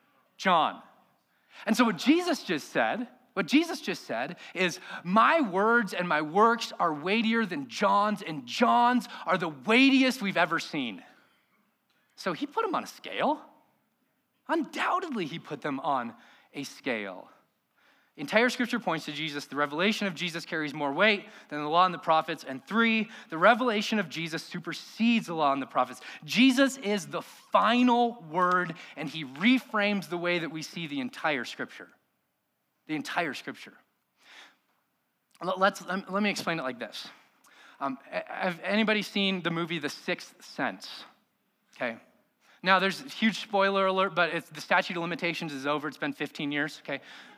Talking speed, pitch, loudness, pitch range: 160 wpm, 195 Hz, -28 LUFS, 165-235 Hz